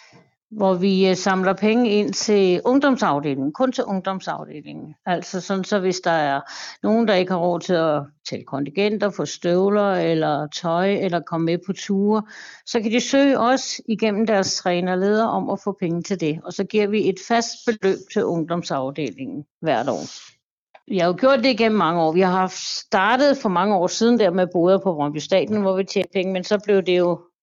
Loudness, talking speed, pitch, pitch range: -20 LUFS, 195 wpm, 190 Hz, 175-215 Hz